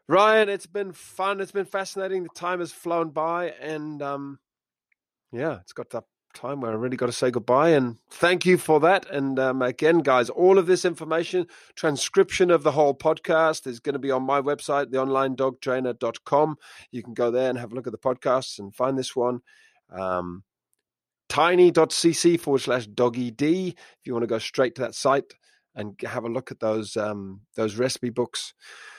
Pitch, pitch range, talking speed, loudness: 140 Hz, 125-170 Hz, 185 wpm, -24 LUFS